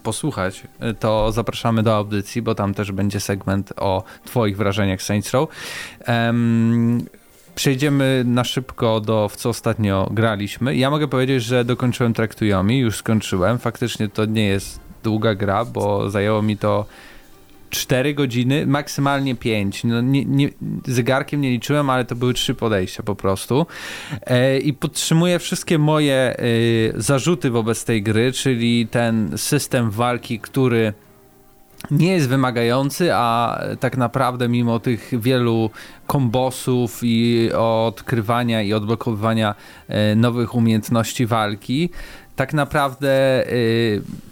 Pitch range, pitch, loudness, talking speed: 110-130 Hz, 120 Hz, -20 LUFS, 125 wpm